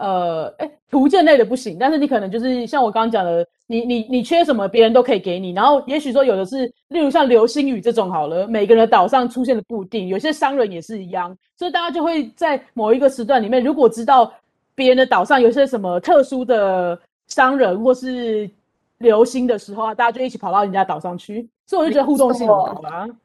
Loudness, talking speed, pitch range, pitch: -17 LUFS, 350 characters per minute, 210-270 Hz, 235 Hz